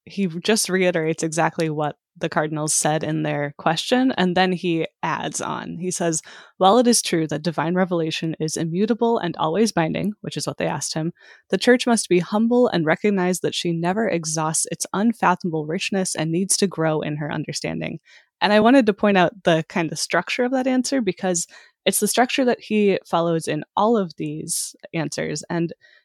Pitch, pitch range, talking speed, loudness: 180 Hz, 160-210 Hz, 190 wpm, -21 LUFS